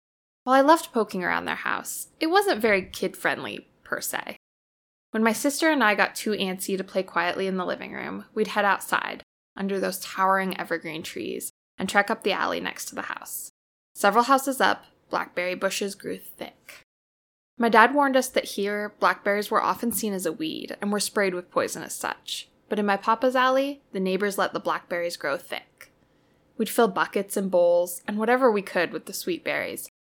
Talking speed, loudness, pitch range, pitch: 195 wpm, -25 LUFS, 190-240 Hz, 205 Hz